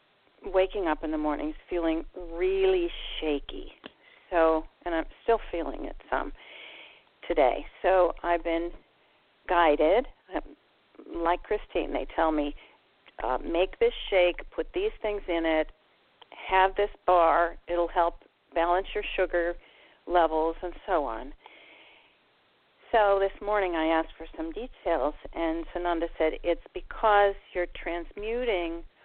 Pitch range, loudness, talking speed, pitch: 165-200 Hz, -28 LUFS, 125 wpm, 175 Hz